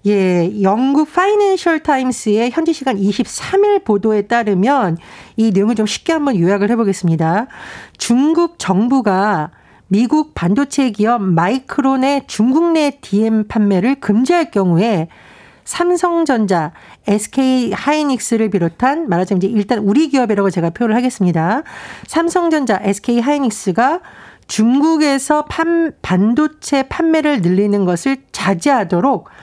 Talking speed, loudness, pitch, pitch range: 285 characters per minute, -15 LUFS, 235 Hz, 200-290 Hz